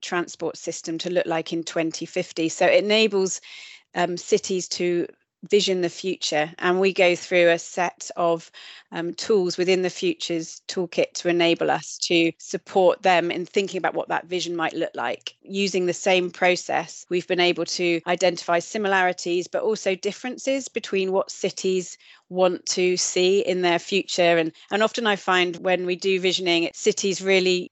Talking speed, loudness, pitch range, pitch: 165 wpm, -23 LUFS, 170-190 Hz, 180 Hz